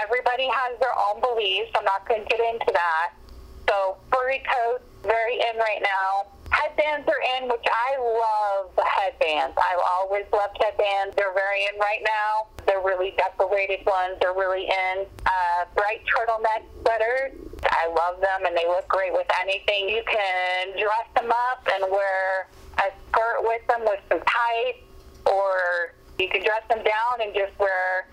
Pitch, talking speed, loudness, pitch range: 210 Hz, 170 wpm, -24 LUFS, 190-235 Hz